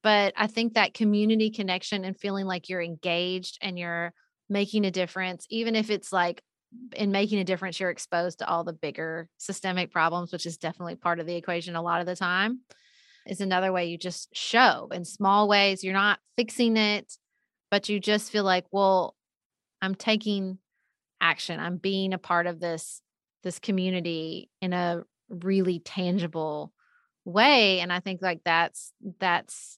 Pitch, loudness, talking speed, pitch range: 190 Hz, -27 LUFS, 170 wpm, 175-210 Hz